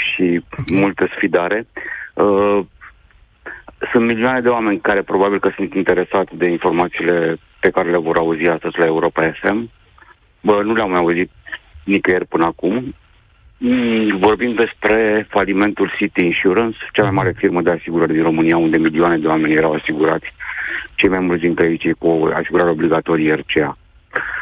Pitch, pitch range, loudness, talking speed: 90 Hz, 85-105 Hz, -16 LUFS, 145 wpm